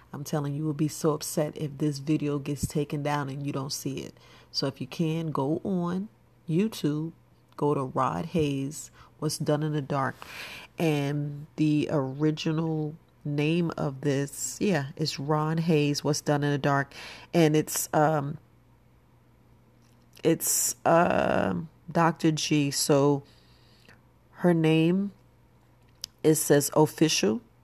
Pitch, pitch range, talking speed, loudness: 150 Hz, 140-155 Hz, 140 wpm, -27 LUFS